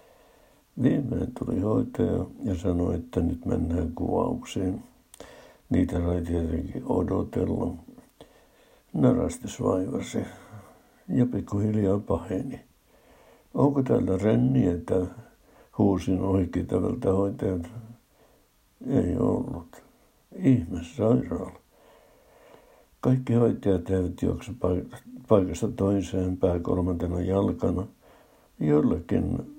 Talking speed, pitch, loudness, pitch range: 80 wpm, 95 Hz, -27 LUFS, 90-115 Hz